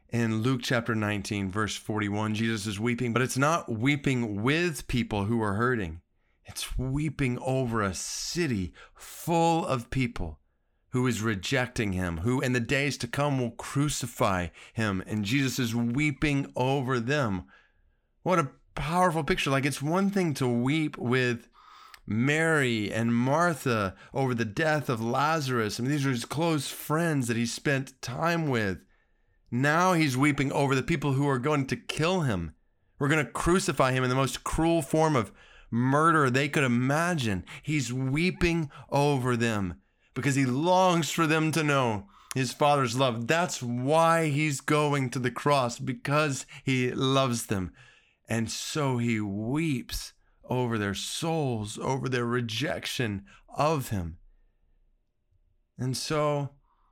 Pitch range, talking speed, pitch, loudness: 115-150 Hz, 150 wpm, 130 Hz, -27 LUFS